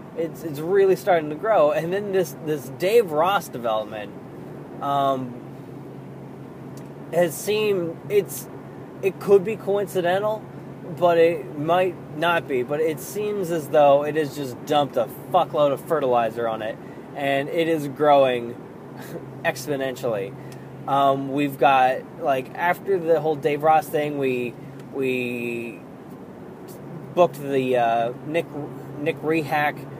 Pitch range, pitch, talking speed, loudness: 135-170 Hz, 150 Hz, 130 wpm, -22 LUFS